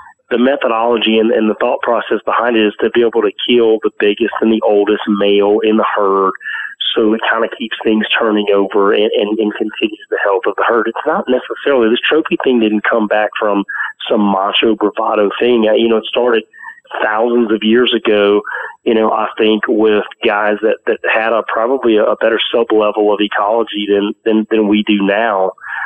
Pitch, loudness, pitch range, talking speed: 110 Hz, -13 LUFS, 105-120 Hz, 205 wpm